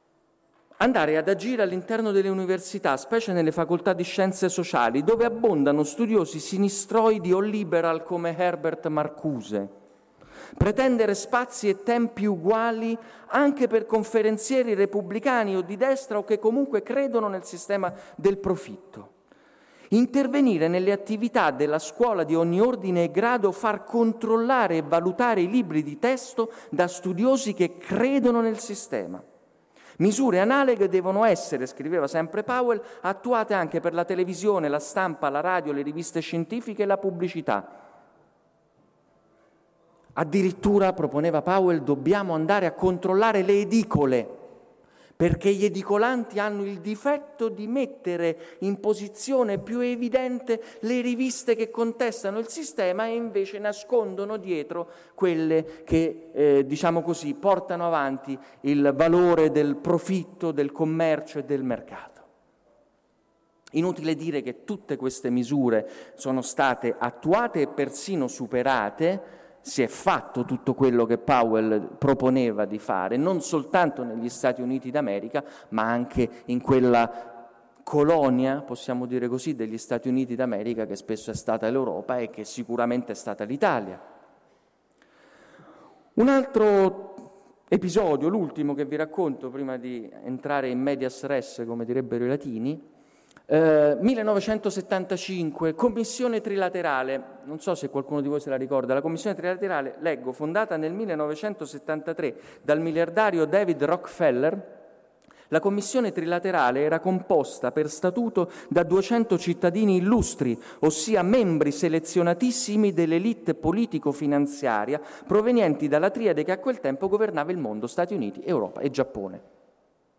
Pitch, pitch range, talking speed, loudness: 180 Hz, 145-215 Hz, 130 wpm, -25 LUFS